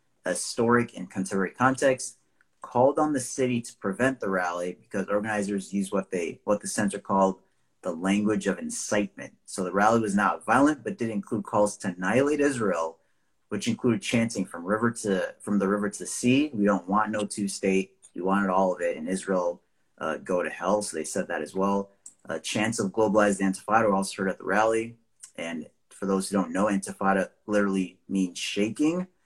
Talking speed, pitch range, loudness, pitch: 195 wpm, 95-115 Hz, -27 LUFS, 105 Hz